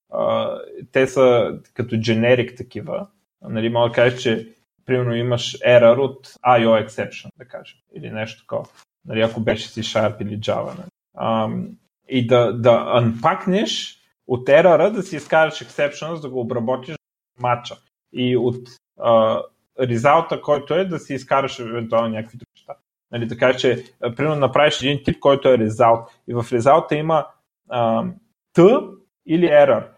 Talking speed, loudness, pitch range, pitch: 155 wpm, -19 LUFS, 115-150 Hz, 125 Hz